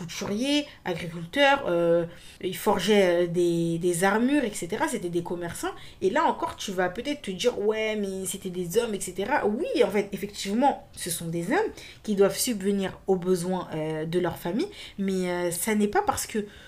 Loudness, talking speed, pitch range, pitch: -26 LUFS, 180 wpm, 175-220 Hz, 195 Hz